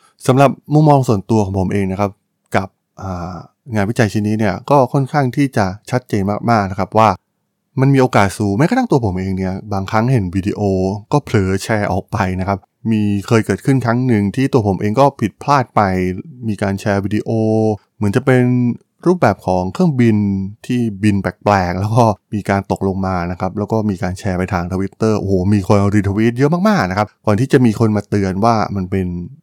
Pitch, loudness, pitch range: 105 Hz, -16 LUFS, 95-125 Hz